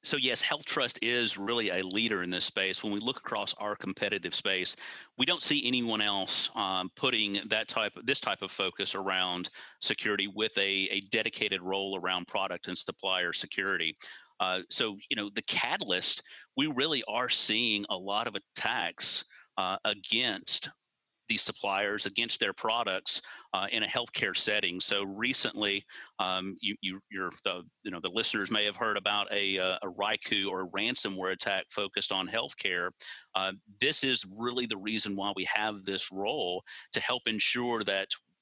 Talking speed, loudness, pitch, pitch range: 175 wpm, -30 LUFS, 100 Hz, 95-110 Hz